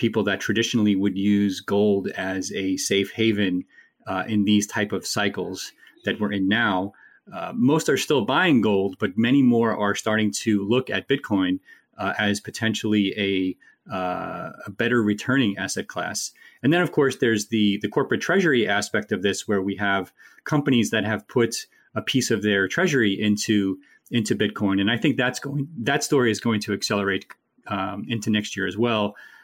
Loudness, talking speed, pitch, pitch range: -23 LUFS, 180 wpm, 105 Hz, 100-115 Hz